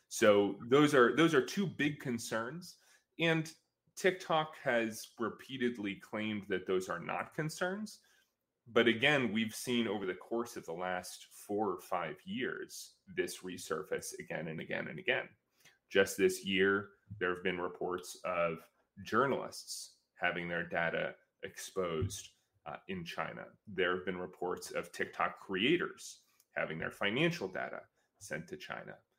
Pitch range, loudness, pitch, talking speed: 95-165 Hz, -35 LUFS, 115 Hz, 140 wpm